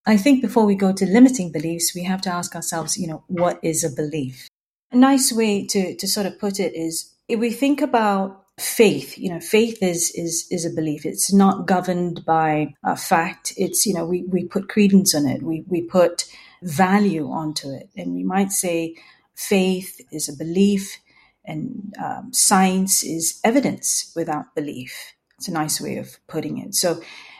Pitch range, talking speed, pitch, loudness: 165-200 Hz, 190 wpm, 185 Hz, -20 LUFS